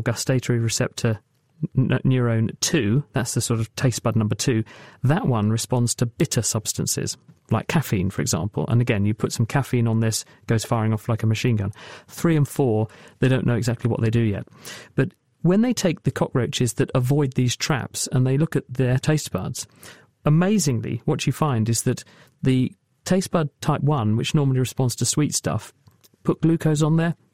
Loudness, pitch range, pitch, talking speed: -22 LUFS, 115-145 Hz, 130 Hz, 190 wpm